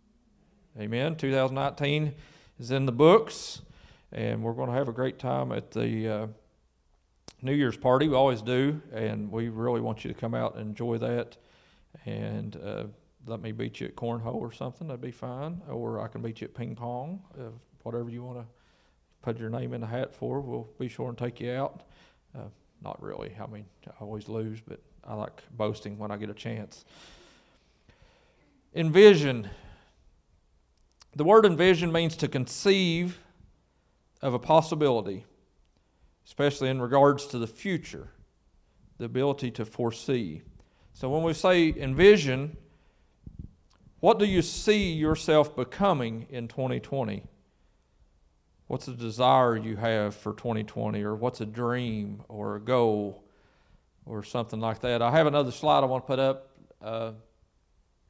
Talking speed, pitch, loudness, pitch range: 155 wpm, 120 Hz, -27 LUFS, 105-140 Hz